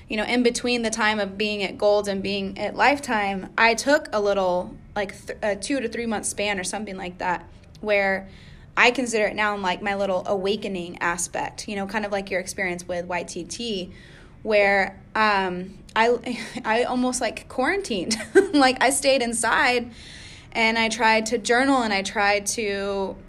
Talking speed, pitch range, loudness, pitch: 180 wpm, 195-235 Hz, -23 LUFS, 210 Hz